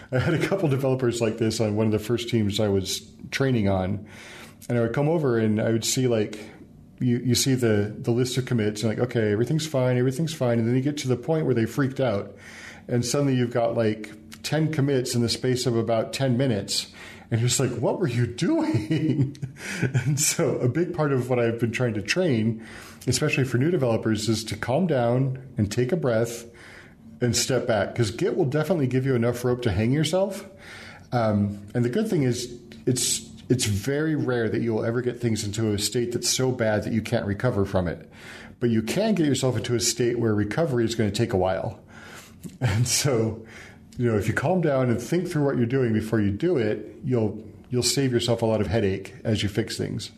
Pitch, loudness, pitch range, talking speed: 120 Hz, -24 LUFS, 110-130 Hz, 220 wpm